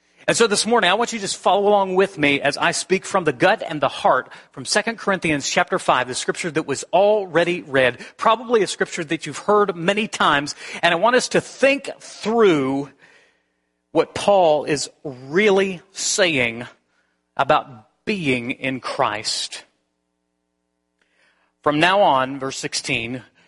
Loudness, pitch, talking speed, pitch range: -19 LUFS, 165 Hz, 160 wpm, 130-195 Hz